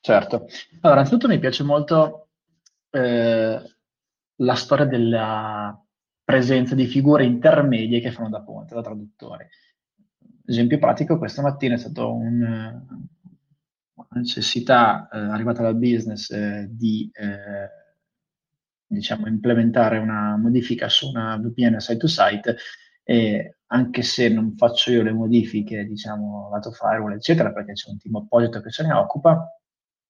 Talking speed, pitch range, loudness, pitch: 135 wpm, 110-150 Hz, -20 LUFS, 120 Hz